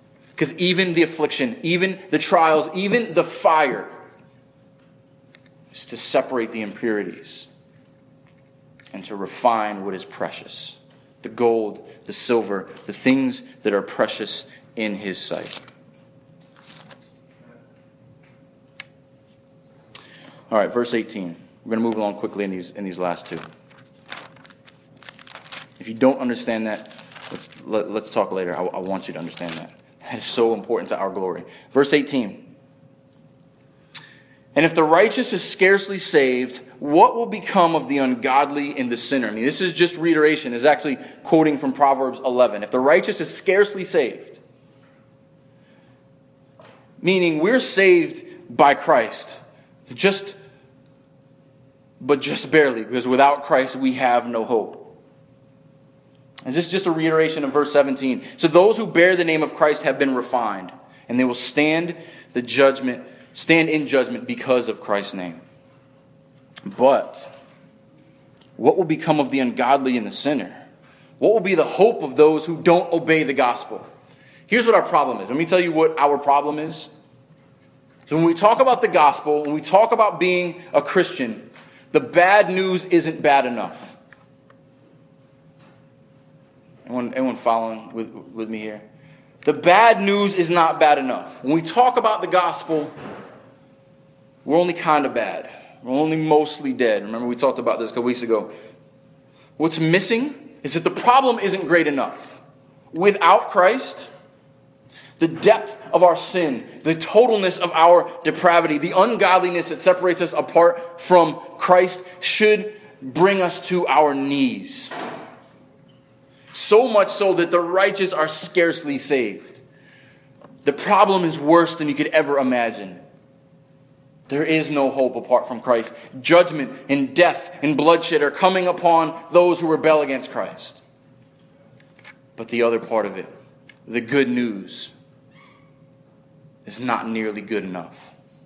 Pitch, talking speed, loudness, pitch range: 150 Hz, 145 wpm, -19 LUFS, 130-175 Hz